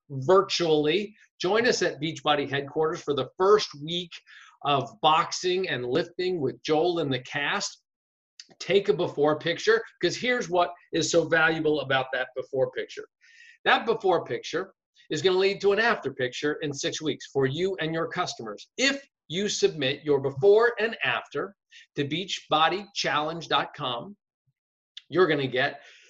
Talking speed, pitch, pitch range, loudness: 150 wpm, 175 Hz, 150-210 Hz, -26 LUFS